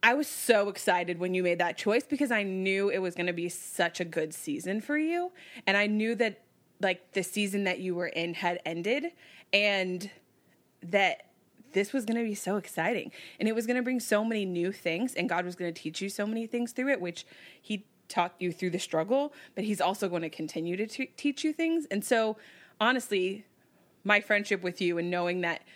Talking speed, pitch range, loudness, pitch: 220 wpm, 180-230 Hz, -30 LUFS, 200 Hz